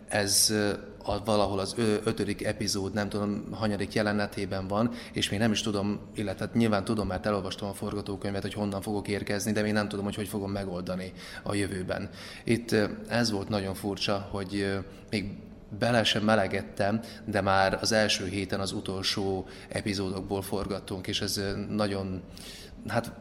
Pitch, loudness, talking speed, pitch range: 100 Hz, -29 LUFS, 160 wpm, 100-105 Hz